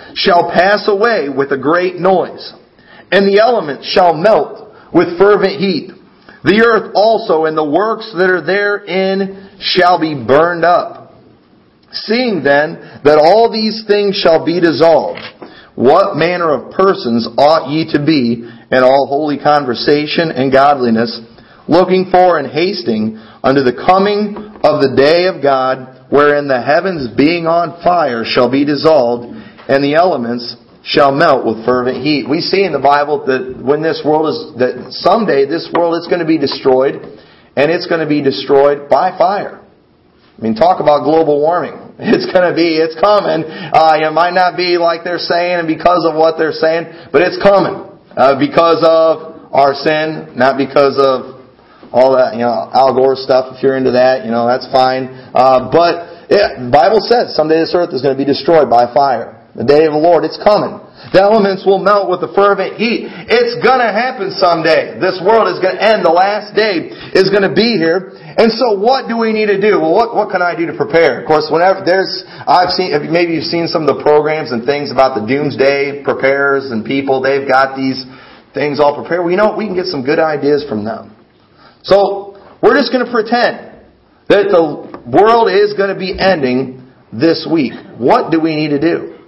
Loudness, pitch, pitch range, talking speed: -12 LUFS, 160 Hz, 135-190 Hz, 190 wpm